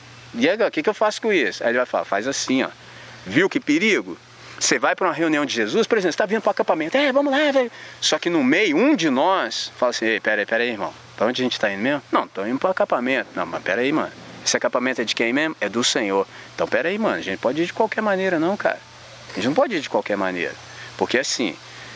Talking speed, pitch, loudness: 255 wpm, 215 Hz, -21 LUFS